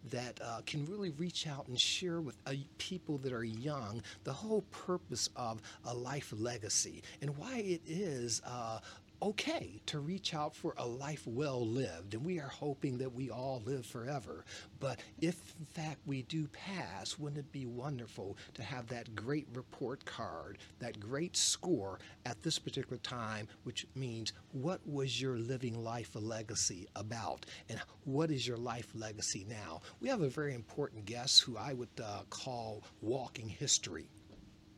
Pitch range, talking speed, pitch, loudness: 110-145 Hz, 170 wpm, 125 Hz, -39 LUFS